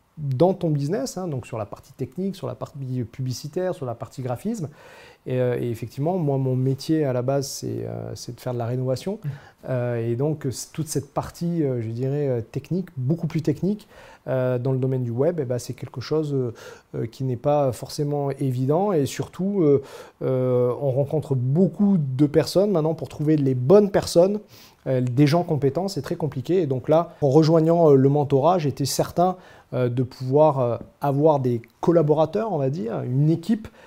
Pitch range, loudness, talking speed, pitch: 130-160 Hz, -23 LUFS, 165 wpm, 140 Hz